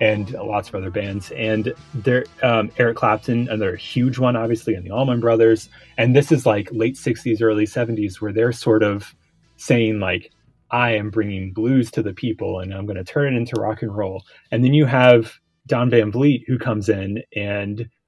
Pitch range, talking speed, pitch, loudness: 105-120 Hz, 200 wpm, 115 Hz, -20 LUFS